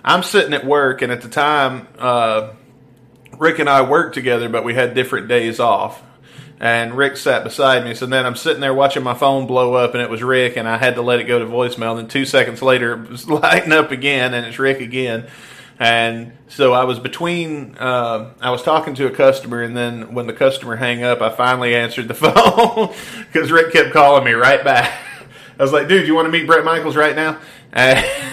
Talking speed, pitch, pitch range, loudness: 220 wpm, 130 Hz, 120-145 Hz, -15 LUFS